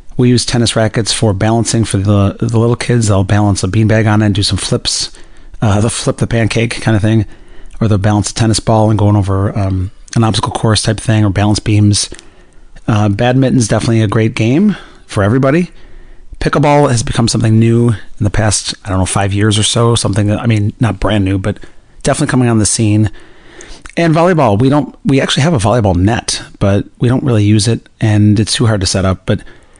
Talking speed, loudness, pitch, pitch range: 220 wpm, -12 LUFS, 110 Hz, 105-120 Hz